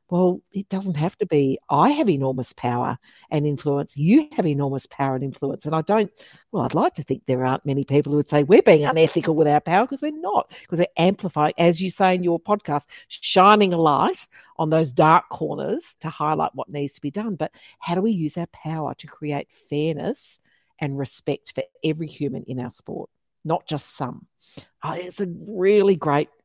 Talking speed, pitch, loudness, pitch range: 205 wpm, 160 Hz, -22 LUFS, 145-185 Hz